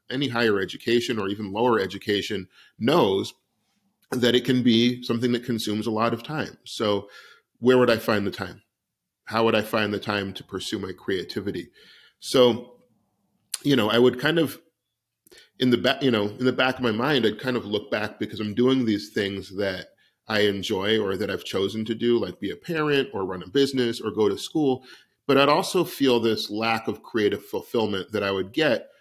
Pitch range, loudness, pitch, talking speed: 105-130 Hz, -24 LUFS, 115 Hz, 205 wpm